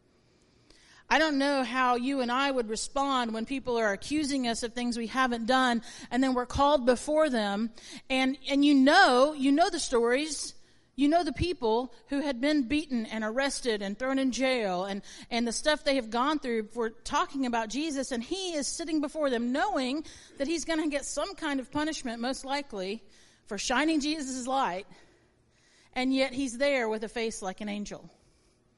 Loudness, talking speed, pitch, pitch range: -29 LUFS, 190 wpm, 260 Hz, 230-285 Hz